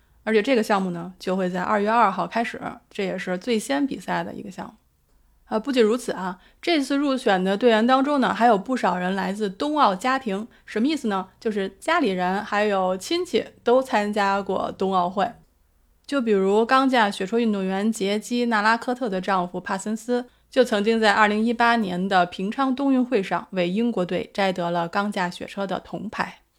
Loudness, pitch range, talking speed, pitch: -23 LUFS, 190-245 Hz, 290 characters per minute, 215 Hz